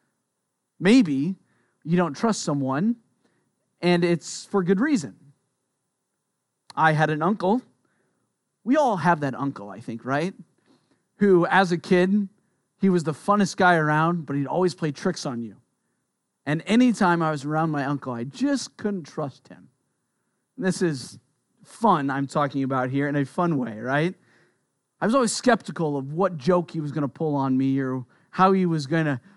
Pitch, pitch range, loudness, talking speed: 165 Hz, 140-190 Hz, -23 LUFS, 170 wpm